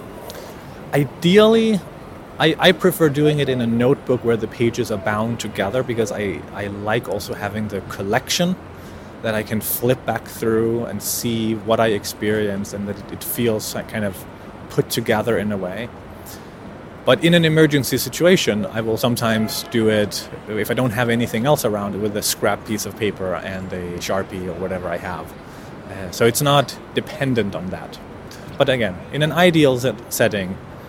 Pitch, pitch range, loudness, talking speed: 110 Hz, 100-130 Hz, -20 LUFS, 175 wpm